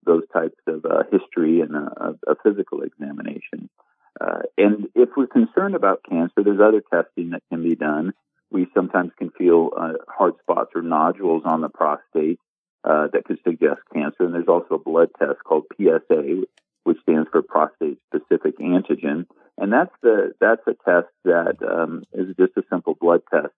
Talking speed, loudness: 175 wpm, -21 LUFS